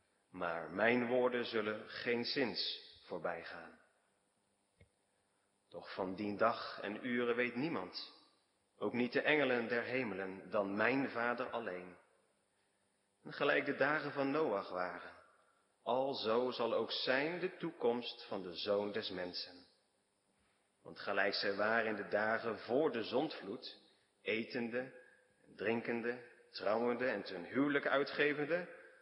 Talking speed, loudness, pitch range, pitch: 130 wpm, -38 LUFS, 100-125 Hz, 115 Hz